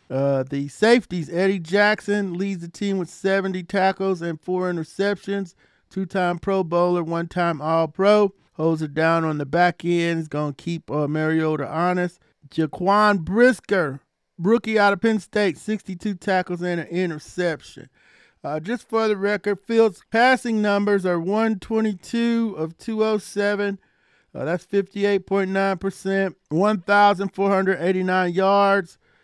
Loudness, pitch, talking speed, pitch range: -22 LUFS, 190 Hz, 125 wpm, 170-205 Hz